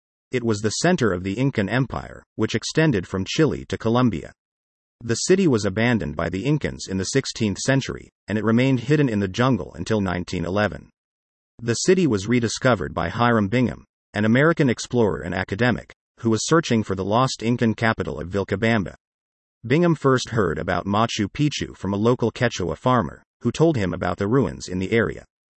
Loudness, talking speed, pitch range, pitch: -22 LUFS, 180 wpm, 95-125 Hz, 110 Hz